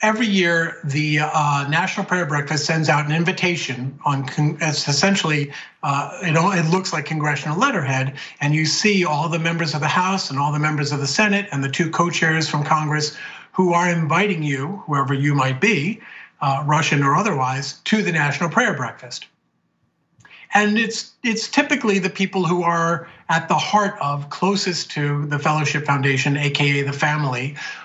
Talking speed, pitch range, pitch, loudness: 175 wpm, 145-180 Hz, 155 Hz, -19 LUFS